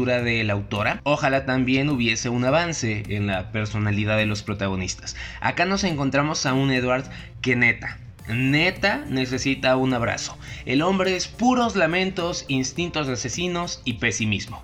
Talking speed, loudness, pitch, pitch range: 150 wpm, -23 LUFS, 130 Hz, 115-145 Hz